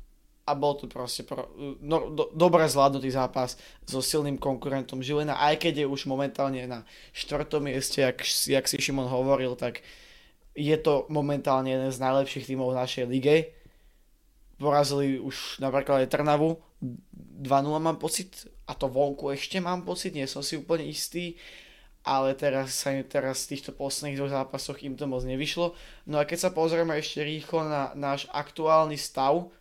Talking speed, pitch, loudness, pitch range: 160 wpm, 140 Hz, -28 LUFS, 135-150 Hz